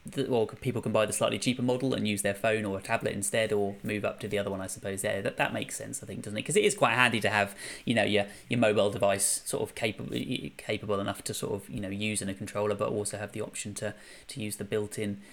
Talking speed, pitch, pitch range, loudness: 285 wpm, 105 Hz, 100-110 Hz, -30 LUFS